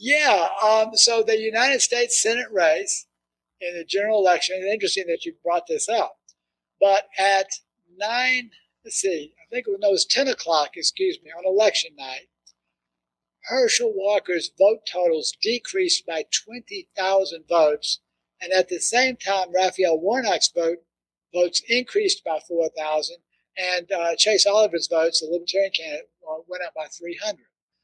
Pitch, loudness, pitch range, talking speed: 195 Hz, -21 LUFS, 170-245 Hz, 150 wpm